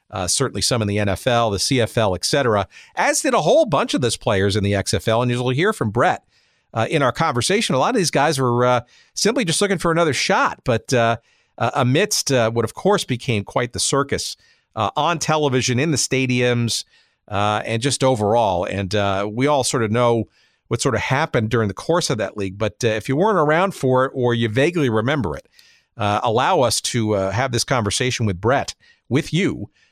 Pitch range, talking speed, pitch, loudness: 110-135 Hz, 215 wpm, 120 Hz, -19 LUFS